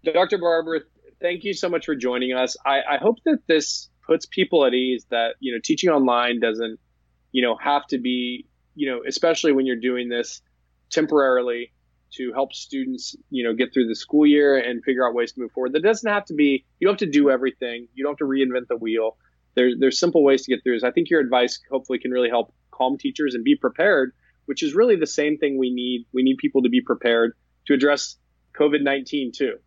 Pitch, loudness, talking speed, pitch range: 130 Hz, -21 LUFS, 225 wpm, 120-150 Hz